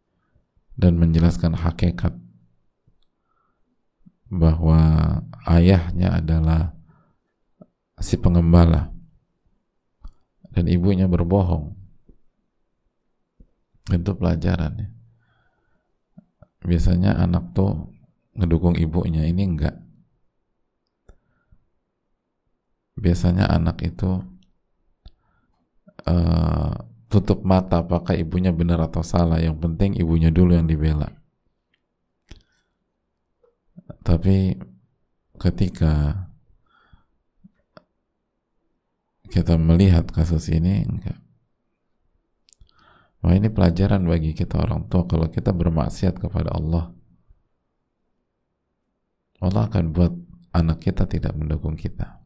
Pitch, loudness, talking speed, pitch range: 85 Hz, -21 LUFS, 75 wpm, 80-95 Hz